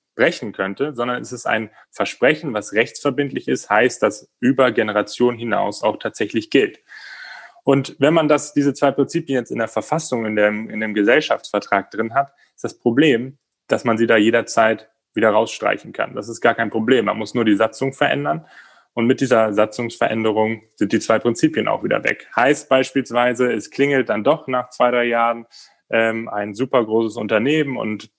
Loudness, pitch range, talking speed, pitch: -19 LUFS, 110-135 Hz, 180 wpm, 120 Hz